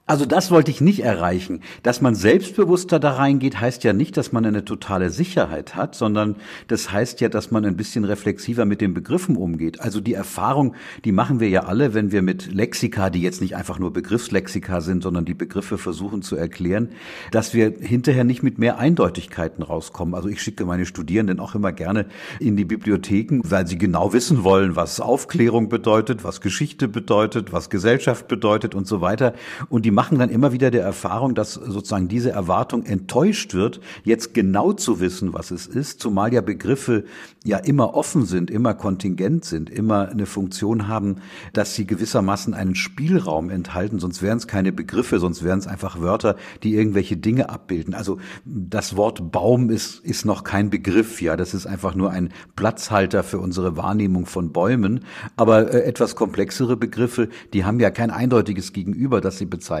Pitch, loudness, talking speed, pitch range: 105 Hz, -21 LUFS, 185 wpm, 95-120 Hz